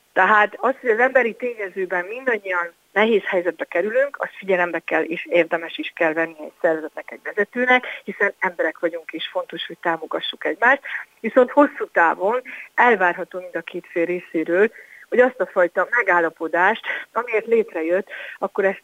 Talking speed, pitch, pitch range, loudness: 155 wpm, 185 Hz, 170-230 Hz, -21 LUFS